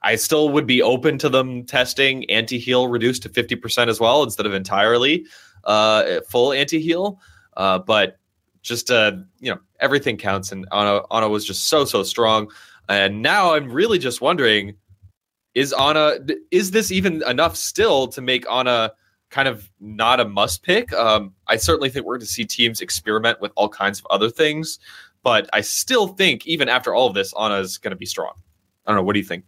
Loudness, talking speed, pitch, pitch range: -19 LUFS, 195 wpm, 115 Hz, 100-135 Hz